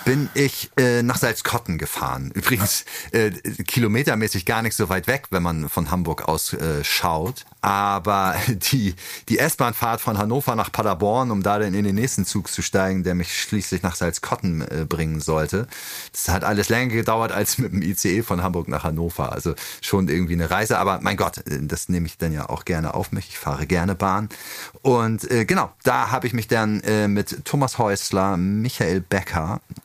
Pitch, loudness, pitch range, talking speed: 100 Hz, -22 LUFS, 90-115 Hz, 190 wpm